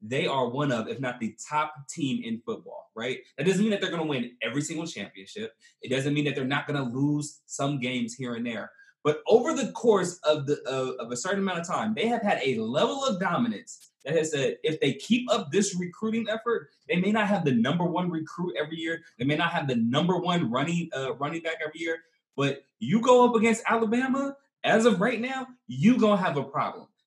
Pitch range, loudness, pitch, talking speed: 145-225 Hz, -27 LUFS, 175 Hz, 235 wpm